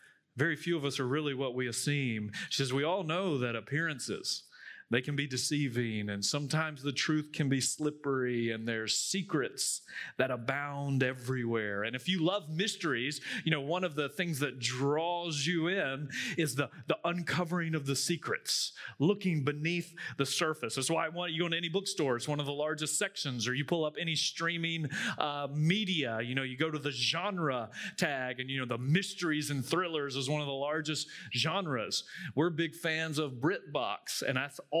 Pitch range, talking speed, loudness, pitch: 135-165 Hz, 195 wpm, -33 LUFS, 150 Hz